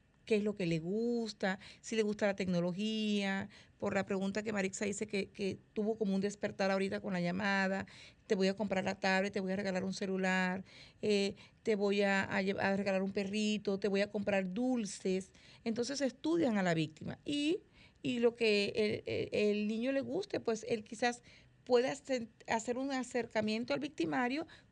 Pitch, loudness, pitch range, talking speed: 210 Hz, -35 LUFS, 195-230 Hz, 185 wpm